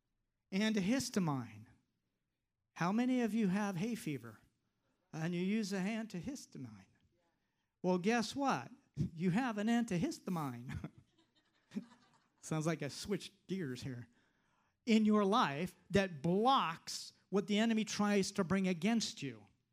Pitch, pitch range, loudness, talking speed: 195 Hz, 145-220 Hz, -37 LUFS, 120 wpm